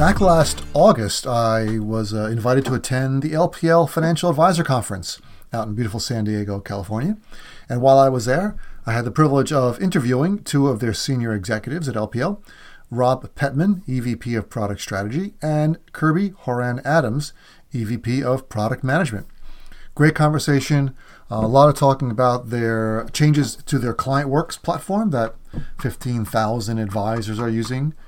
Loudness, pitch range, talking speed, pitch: -20 LUFS, 115-150 Hz, 150 wpm, 130 Hz